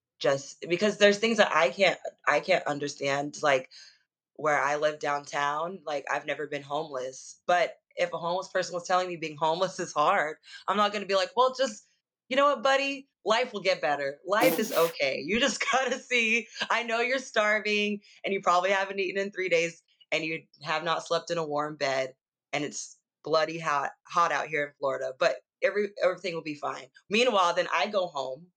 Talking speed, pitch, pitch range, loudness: 205 wpm, 175 Hz, 150-210 Hz, -28 LUFS